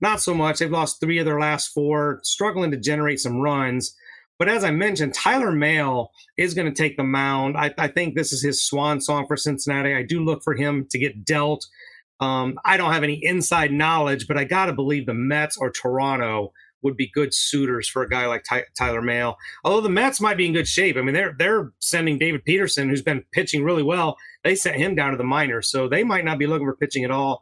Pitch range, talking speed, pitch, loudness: 135-160 Hz, 235 wpm, 145 Hz, -21 LUFS